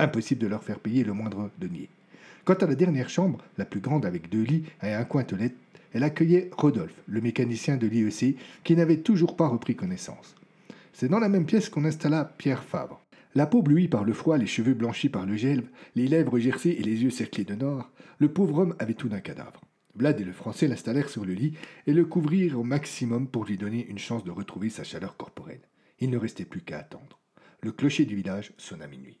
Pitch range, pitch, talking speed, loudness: 115-165 Hz, 135 Hz, 220 wpm, -27 LUFS